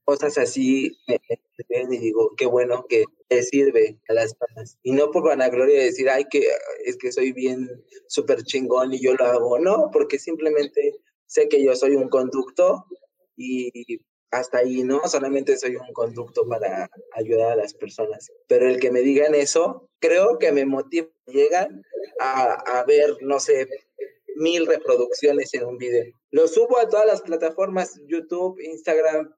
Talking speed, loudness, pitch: 175 wpm, -21 LUFS, 185 Hz